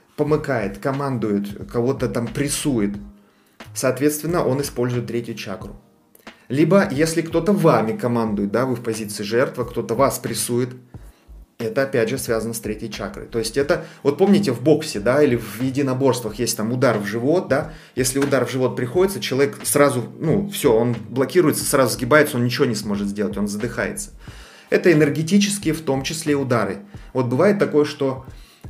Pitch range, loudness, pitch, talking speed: 115-150 Hz, -20 LUFS, 130 Hz, 160 wpm